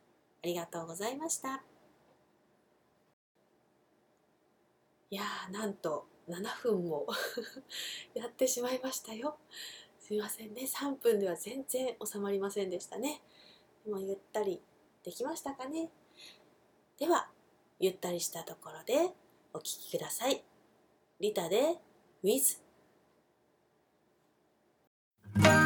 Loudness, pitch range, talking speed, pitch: -36 LUFS, 185-265 Hz, 205 characters per minute, 220 Hz